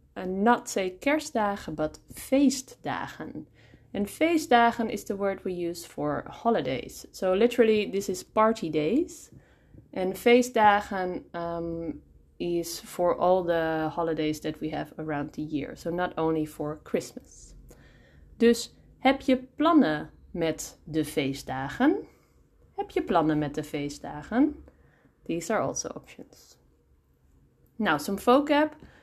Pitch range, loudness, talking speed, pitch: 155-240 Hz, -27 LUFS, 125 wpm, 185 Hz